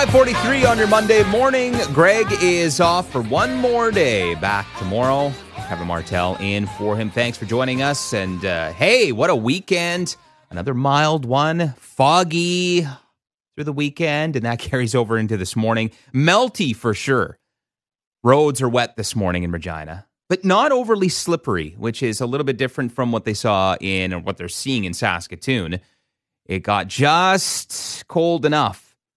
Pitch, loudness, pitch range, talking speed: 130 Hz, -19 LUFS, 105-170 Hz, 165 wpm